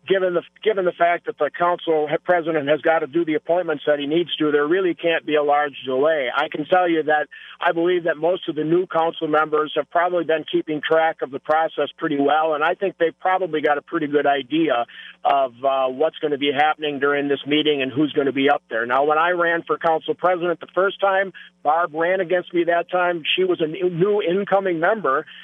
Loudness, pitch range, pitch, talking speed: -20 LUFS, 150-175 Hz, 160 Hz, 235 wpm